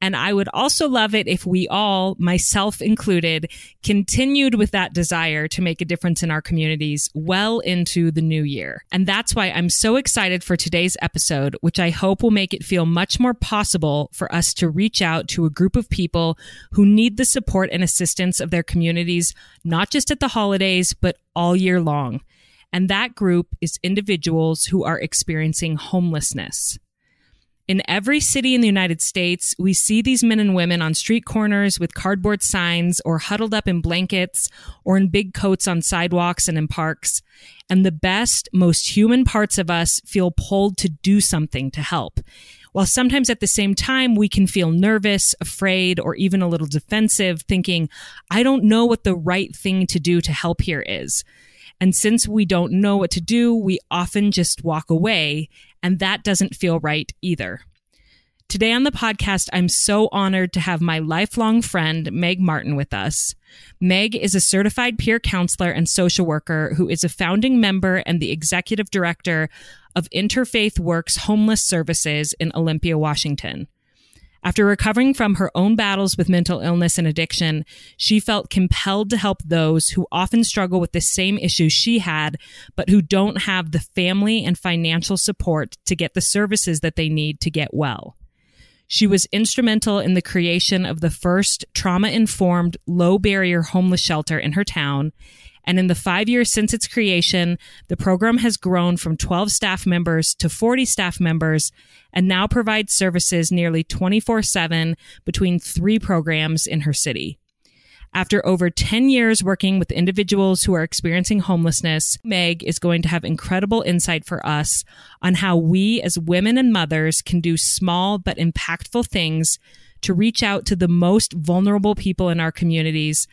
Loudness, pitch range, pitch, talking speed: -19 LUFS, 165-205 Hz, 180 Hz, 175 wpm